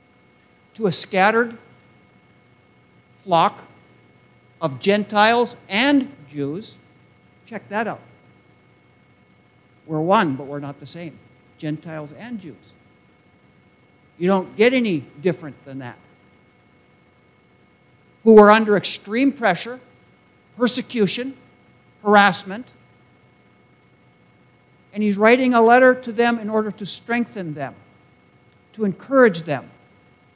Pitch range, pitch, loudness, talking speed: 145-230 Hz, 195 Hz, -18 LUFS, 100 wpm